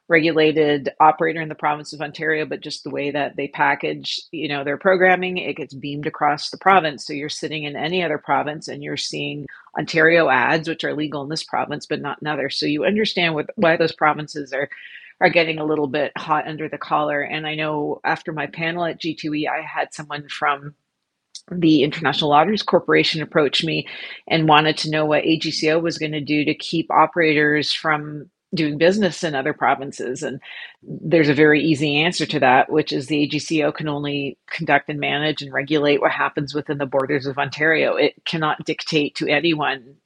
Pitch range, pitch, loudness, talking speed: 145-160 Hz, 150 Hz, -20 LUFS, 195 wpm